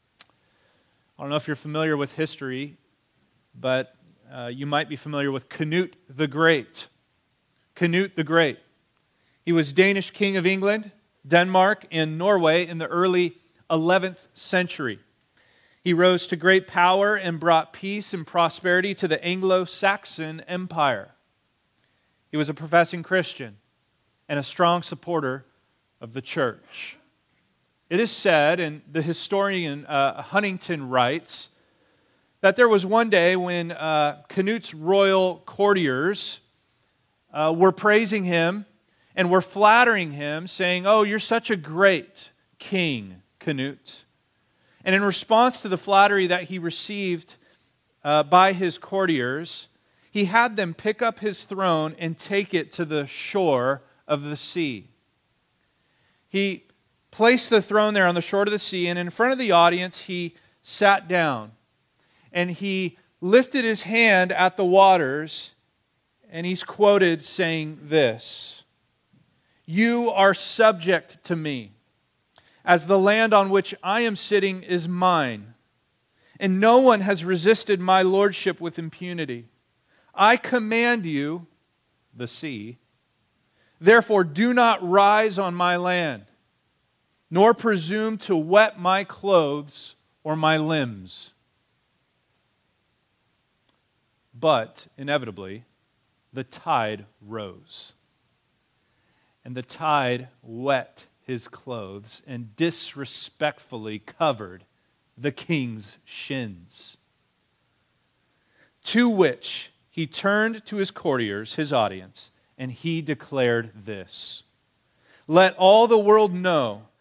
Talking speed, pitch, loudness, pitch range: 125 wpm, 170 Hz, -22 LUFS, 140-195 Hz